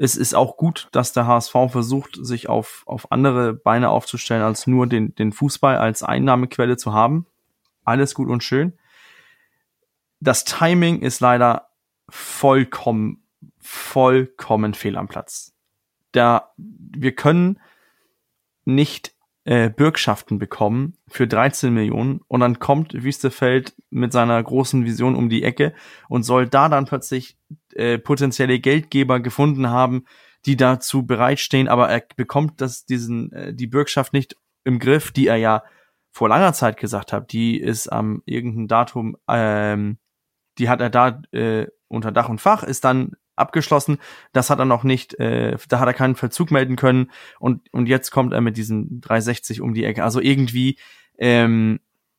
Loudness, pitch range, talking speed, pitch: -19 LUFS, 120-140 Hz, 155 wpm, 125 Hz